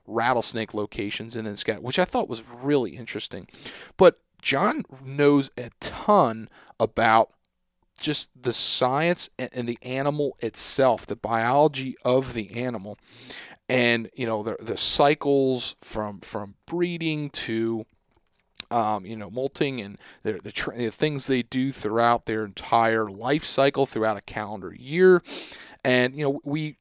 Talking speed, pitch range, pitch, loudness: 140 wpm, 110-140 Hz, 125 Hz, -24 LUFS